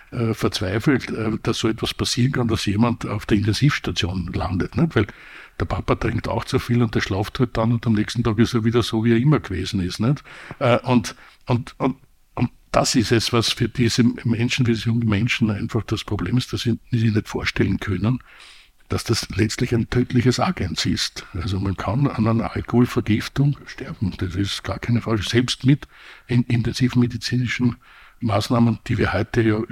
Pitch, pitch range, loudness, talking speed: 115 Hz, 105-120 Hz, -21 LUFS, 185 wpm